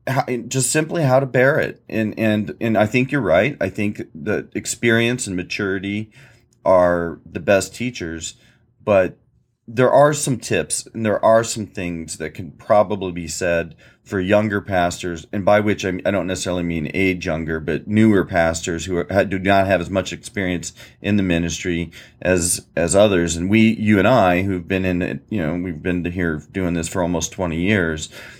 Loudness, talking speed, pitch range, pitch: -19 LUFS, 190 wpm, 85-110 Hz, 95 Hz